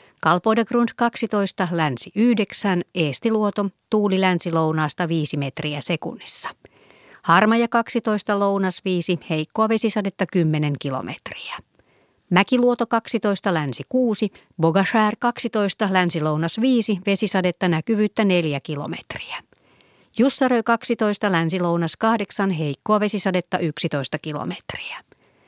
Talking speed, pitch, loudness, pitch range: 95 wpm, 195 Hz, -21 LUFS, 165-220 Hz